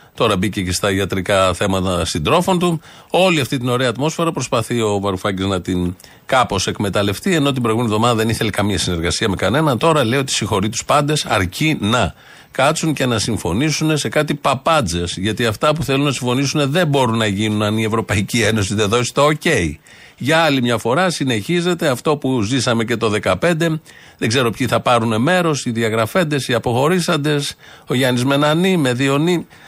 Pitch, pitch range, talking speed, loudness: 125 Hz, 105-150 Hz, 180 wpm, -17 LUFS